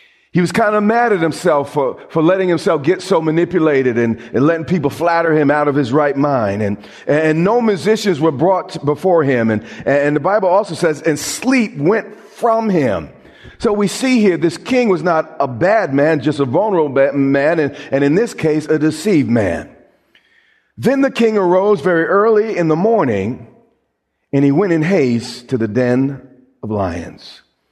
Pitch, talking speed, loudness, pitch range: 160 Hz, 190 wpm, -15 LUFS, 140-205 Hz